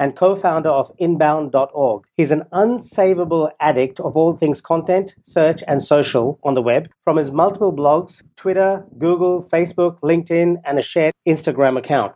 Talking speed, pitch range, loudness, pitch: 160 wpm, 145-180 Hz, -17 LUFS, 165 Hz